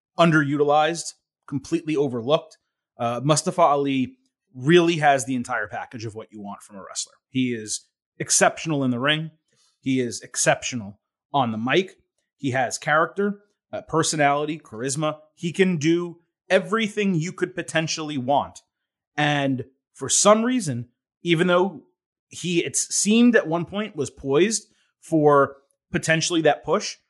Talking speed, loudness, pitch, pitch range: 135 wpm, -22 LUFS, 155 Hz, 135-175 Hz